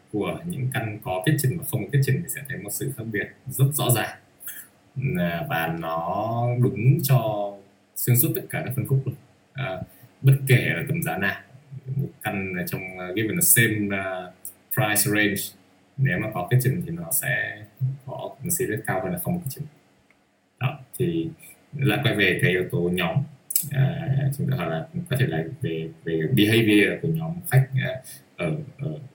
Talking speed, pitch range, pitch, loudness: 175 wpm, 100-145 Hz, 130 Hz, -24 LUFS